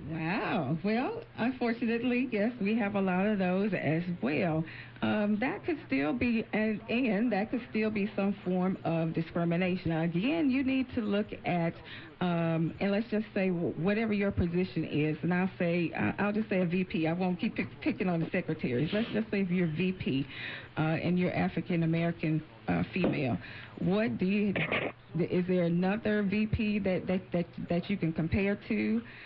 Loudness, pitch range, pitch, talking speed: -31 LUFS, 165-210 Hz, 185 Hz, 175 wpm